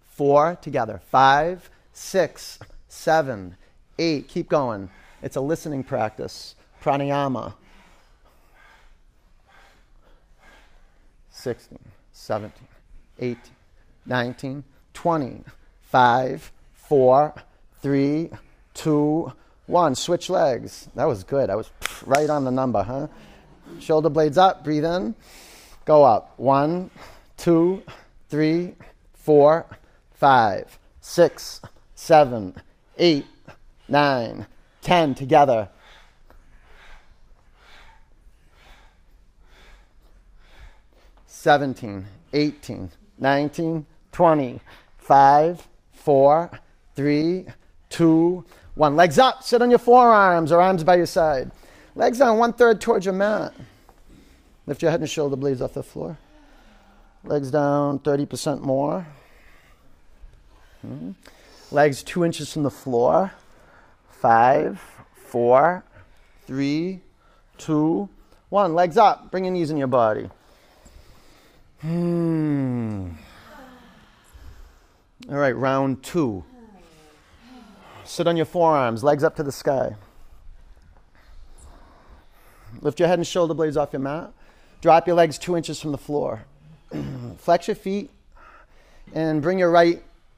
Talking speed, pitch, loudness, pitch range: 100 wpm, 145 Hz, -21 LUFS, 120-170 Hz